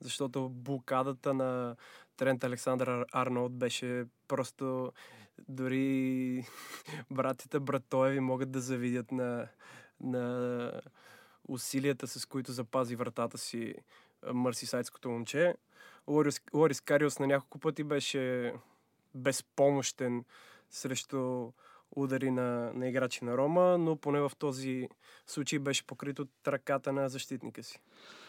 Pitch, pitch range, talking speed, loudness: 130 Hz, 125-140 Hz, 110 wpm, -34 LUFS